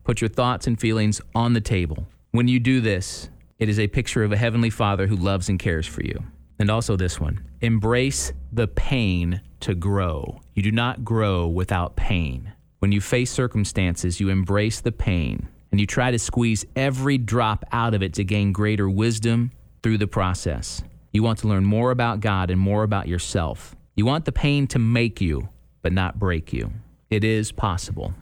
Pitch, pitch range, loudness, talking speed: 105 Hz, 95-115 Hz, -23 LUFS, 195 wpm